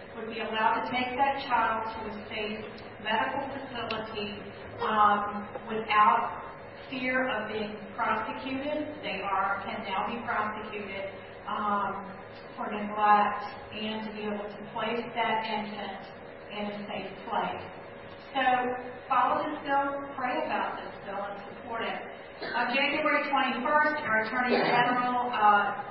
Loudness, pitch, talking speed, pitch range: -29 LUFS, 220 Hz, 135 wpm, 210-255 Hz